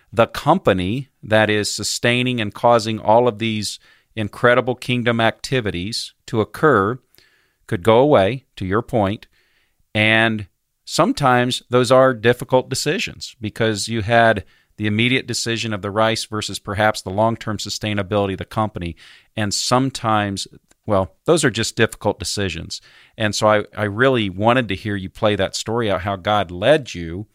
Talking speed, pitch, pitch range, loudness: 150 wpm, 110 Hz, 100-120 Hz, -19 LUFS